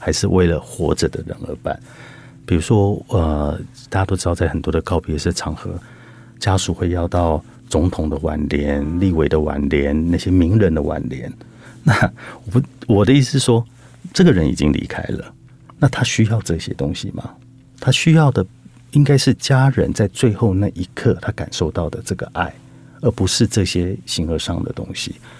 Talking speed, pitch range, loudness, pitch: 260 characters per minute, 85-125 Hz, -18 LUFS, 100 Hz